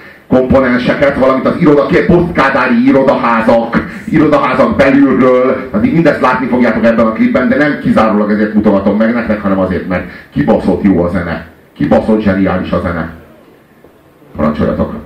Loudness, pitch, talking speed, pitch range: -10 LUFS, 110 Hz, 135 wpm, 95-130 Hz